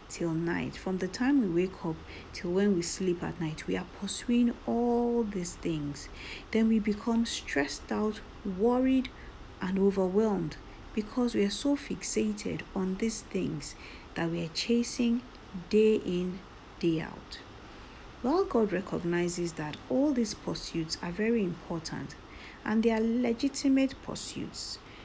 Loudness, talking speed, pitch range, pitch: -31 LUFS, 140 wpm, 175-235 Hz, 205 Hz